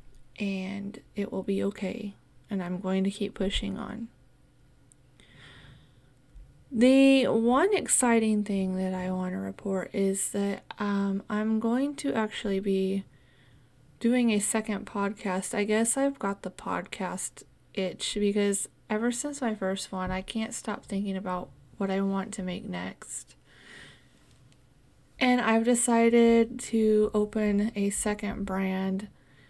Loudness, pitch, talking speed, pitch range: -28 LUFS, 200 Hz, 130 wpm, 190-225 Hz